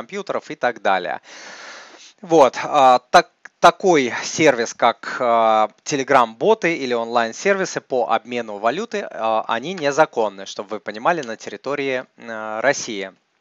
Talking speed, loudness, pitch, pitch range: 110 wpm, -19 LUFS, 120 Hz, 110-145 Hz